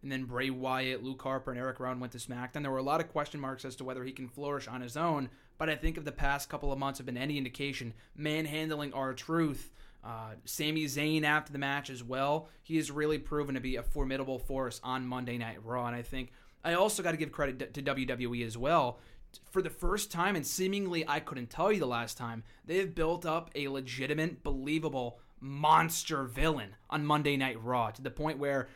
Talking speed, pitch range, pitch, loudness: 230 wpm, 130-155 Hz, 140 Hz, -34 LUFS